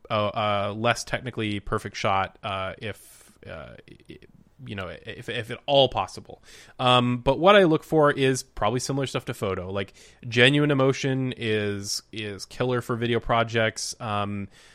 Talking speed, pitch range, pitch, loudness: 160 wpm, 105-130 Hz, 120 Hz, -24 LUFS